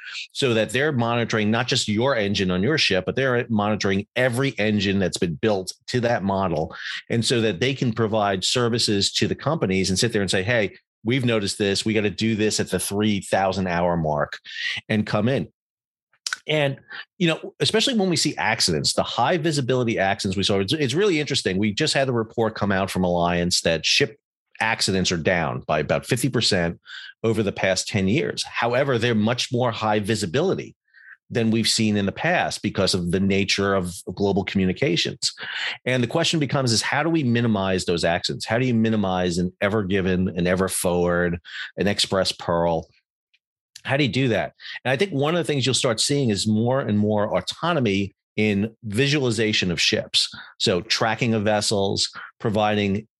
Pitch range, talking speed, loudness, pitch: 95-125 Hz, 185 wpm, -22 LUFS, 110 Hz